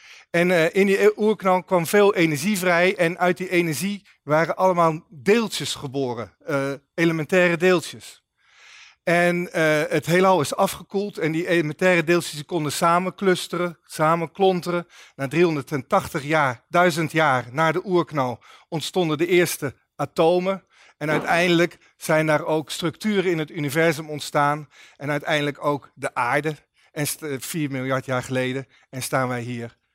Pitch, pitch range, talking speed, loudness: 165 Hz, 145-180 Hz, 130 wpm, -22 LUFS